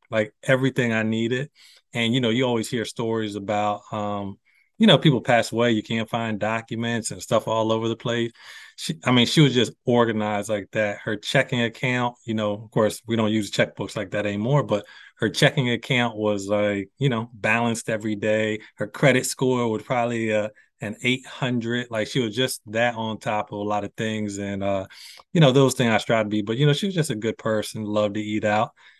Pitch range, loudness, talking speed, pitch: 105-125 Hz, -23 LUFS, 220 wpm, 115 Hz